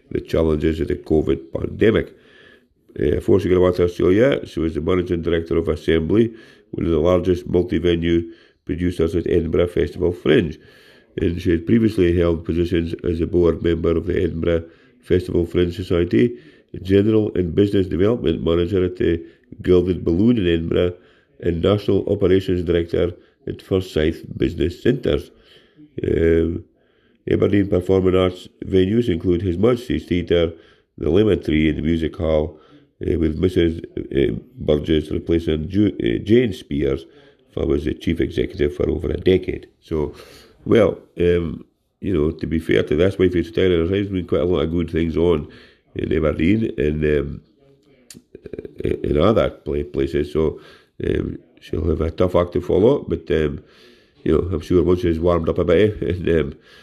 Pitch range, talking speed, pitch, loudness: 80-95 Hz, 160 wpm, 85 Hz, -20 LUFS